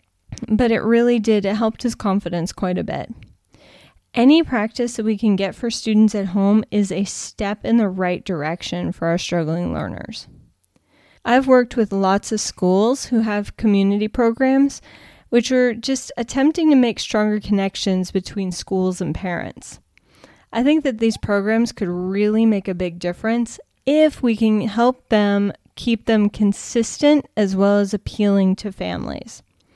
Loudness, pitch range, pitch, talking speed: -19 LUFS, 195-235 Hz, 210 Hz, 160 wpm